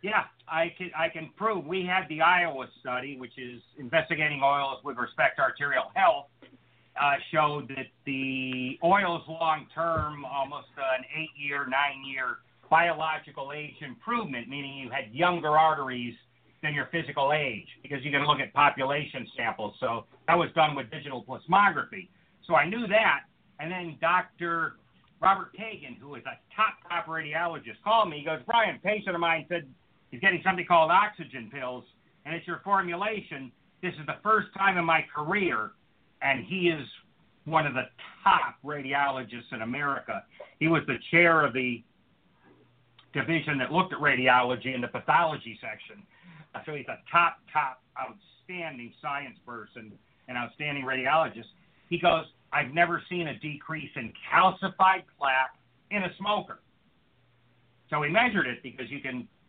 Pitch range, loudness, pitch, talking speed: 130-170 Hz, -27 LUFS, 150 Hz, 160 wpm